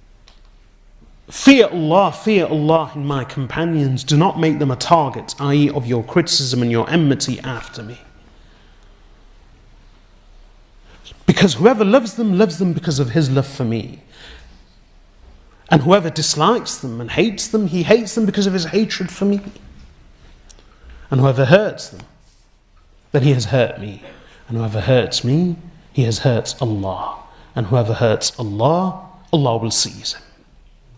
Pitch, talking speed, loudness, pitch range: 135 Hz, 145 wpm, -17 LUFS, 110-170 Hz